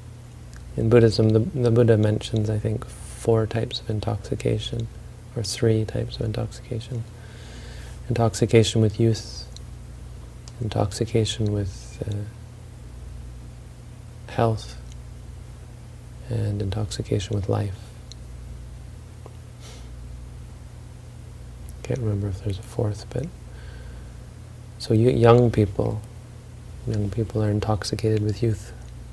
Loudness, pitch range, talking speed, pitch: -24 LUFS, 105-115 Hz, 95 wpm, 110 Hz